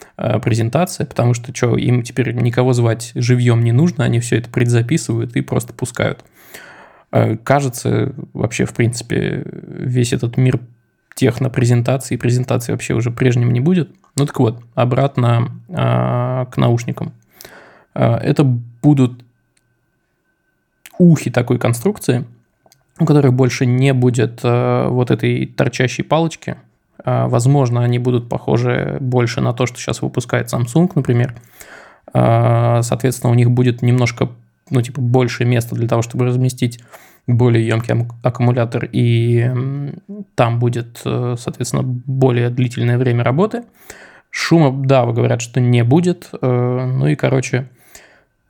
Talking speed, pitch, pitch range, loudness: 120 wpm, 125 Hz, 120-135 Hz, -16 LUFS